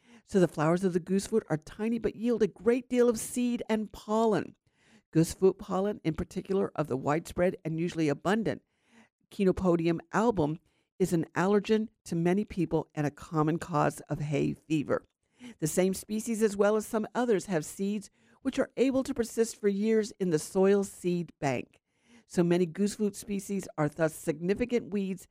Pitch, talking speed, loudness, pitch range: 195 Hz, 170 wpm, -30 LUFS, 165-220 Hz